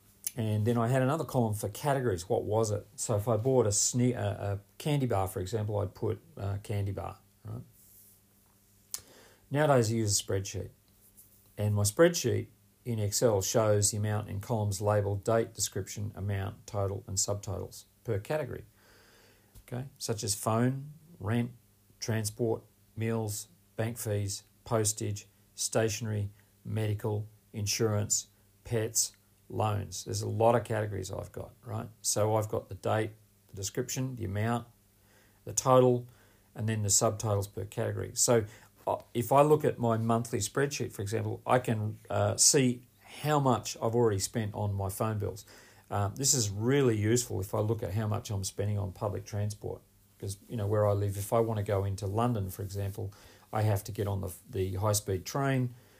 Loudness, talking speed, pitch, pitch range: -31 LUFS, 165 wpm, 105 Hz, 100-115 Hz